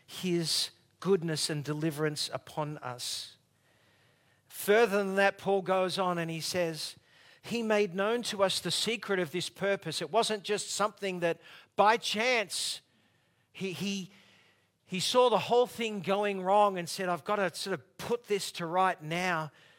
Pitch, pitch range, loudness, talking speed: 185 Hz, 155-200 Hz, -30 LUFS, 160 wpm